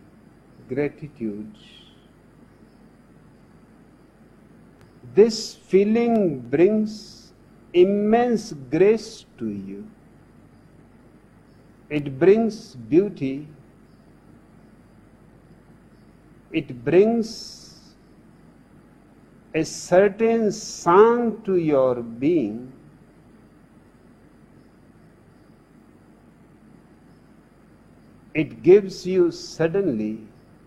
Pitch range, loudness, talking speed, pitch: 140-215 Hz, -21 LUFS, 45 wpm, 180 Hz